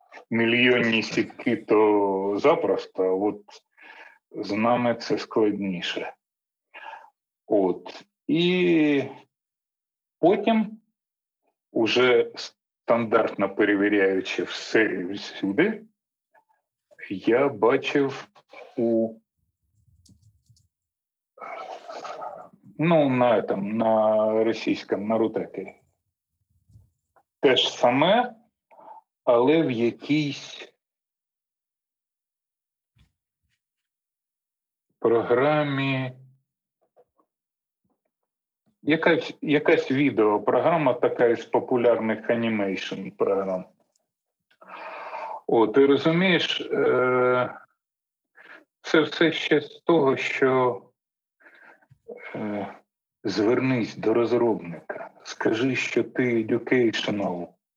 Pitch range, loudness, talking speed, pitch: 105-150 Hz, -23 LUFS, 60 wpm, 120 Hz